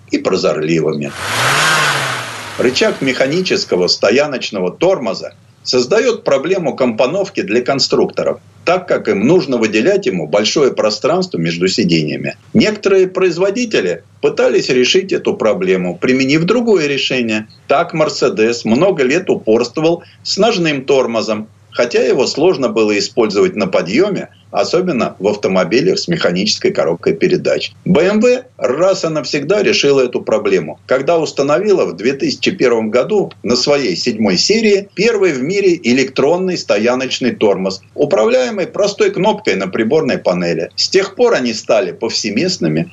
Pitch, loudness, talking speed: 150 Hz, -14 LUFS, 120 wpm